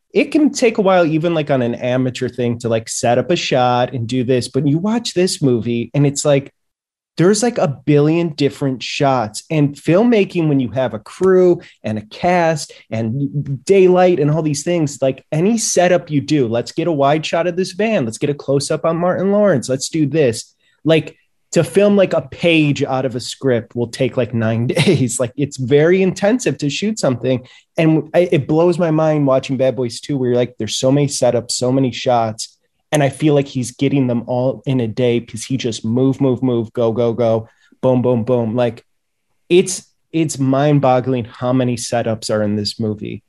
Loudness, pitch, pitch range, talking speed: -16 LUFS, 135 Hz, 125-165 Hz, 205 wpm